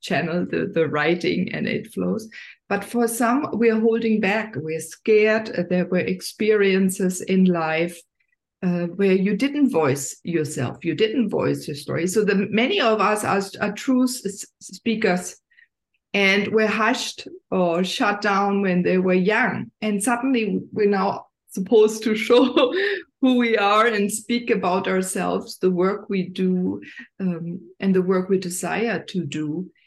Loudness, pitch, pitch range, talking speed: -21 LUFS, 200 Hz, 180-225 Hz, 155 wpm